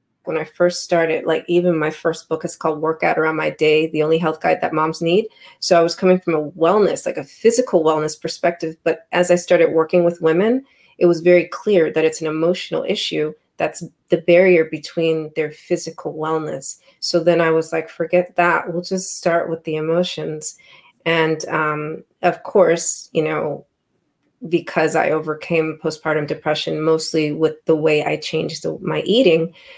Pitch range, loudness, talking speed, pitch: 155-175 Hz, -18 LUFS, 180 wpm, 165 Hz